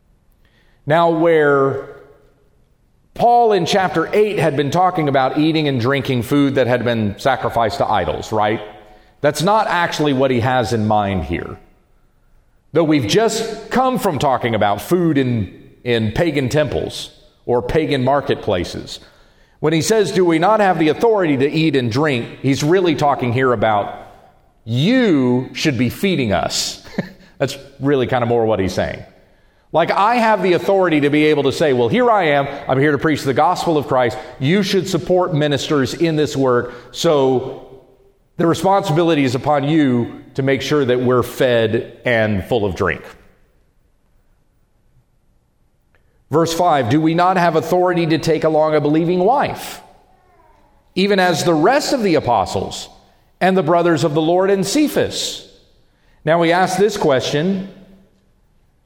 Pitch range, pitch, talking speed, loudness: 125-175 Hz, 150 Hz, 155 wpm, -16 LUFS